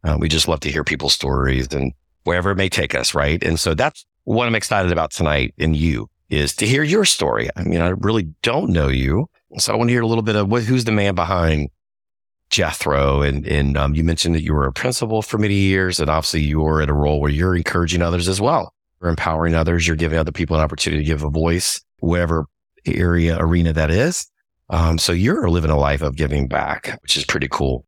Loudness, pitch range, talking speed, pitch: -18 LUFS, 75-90 Hz, 235 wpm, 80 Hz